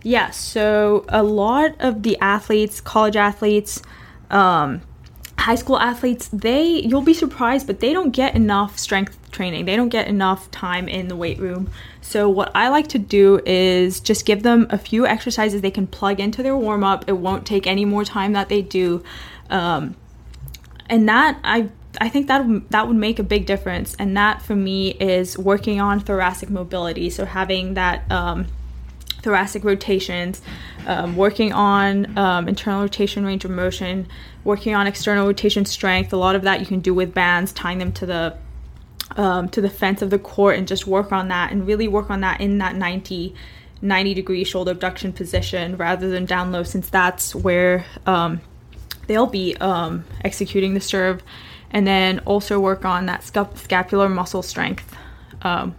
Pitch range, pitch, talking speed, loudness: 185-210 Hz, 195 Hz, 175 wpm, -19 LUFS